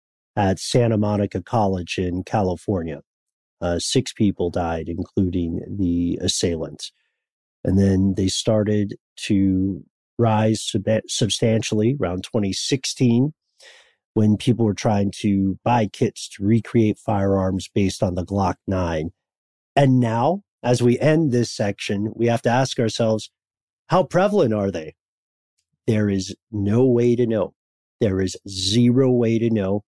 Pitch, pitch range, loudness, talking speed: 105 Hz, 95-120 Hz, -21 LUFS, 135 wpm